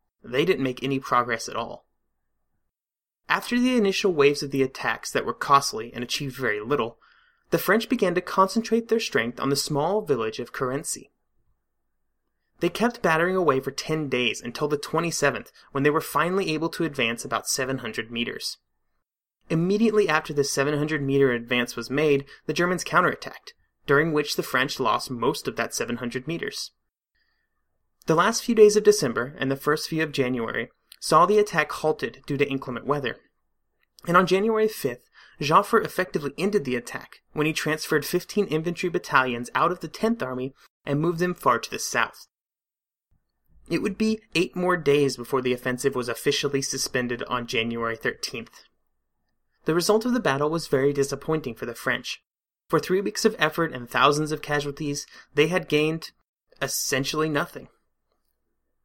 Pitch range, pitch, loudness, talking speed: 135-185 Hz, 150 Hz, -24 LUFS, 170 wpm